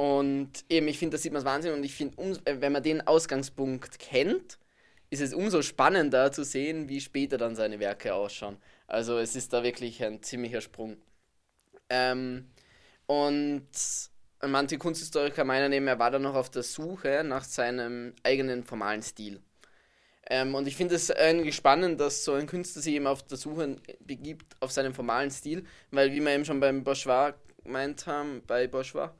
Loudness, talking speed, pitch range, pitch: -29 LUFS, 180 wpm, 125-145 Hz, 135 Hz